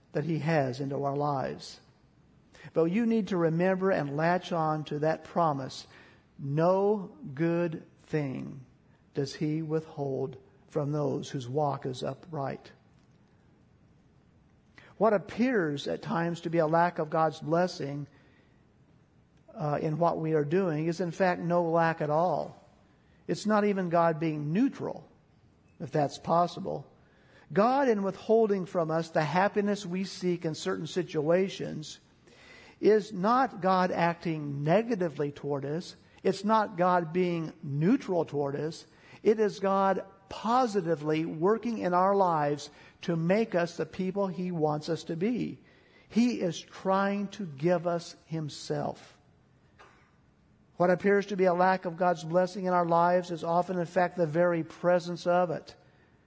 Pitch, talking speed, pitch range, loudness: 170 Hz, 145 wpm, 155-190 Hz, -29 LUFS